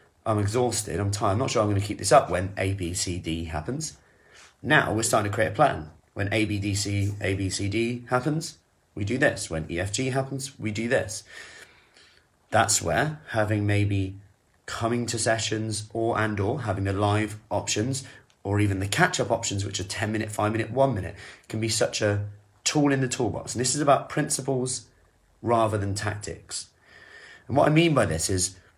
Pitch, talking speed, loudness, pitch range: 105 Hz, 190 wpm, -26 LUFS, 100-120 Hz